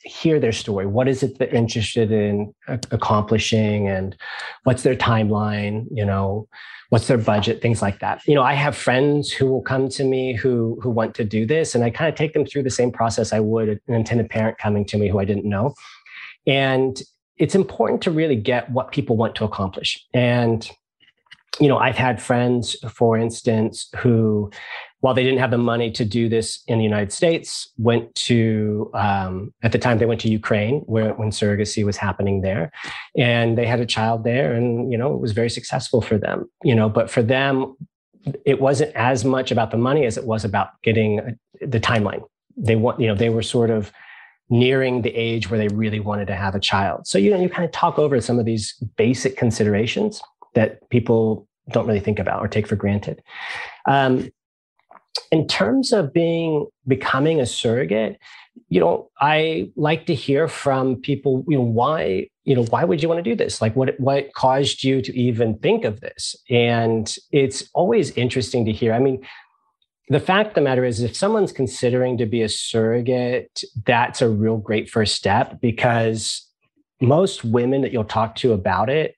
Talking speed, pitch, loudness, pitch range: 195 wpm, 120 Hz, -20 LUFS, 110-130 Hz